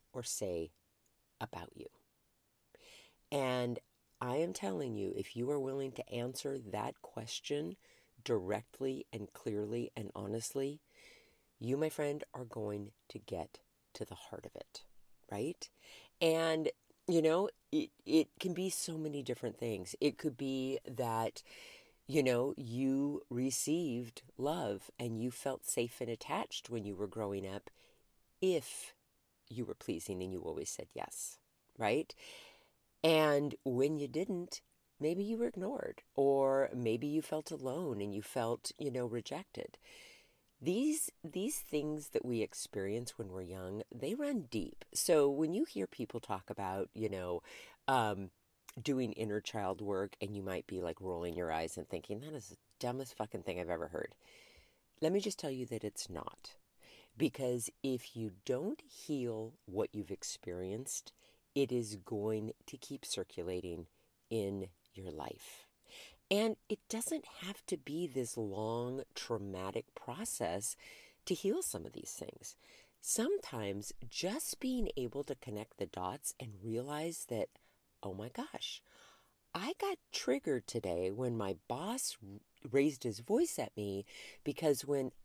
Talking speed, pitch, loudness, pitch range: 145 wpm, 125 Hz, -39 LUFS, 105-155 Hz